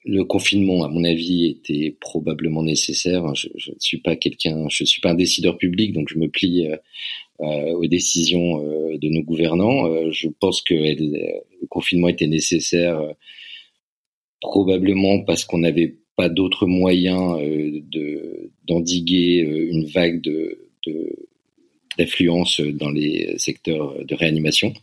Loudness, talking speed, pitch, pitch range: -20 LUFS, 150 wpm, 85 Hz, 80-90 Hz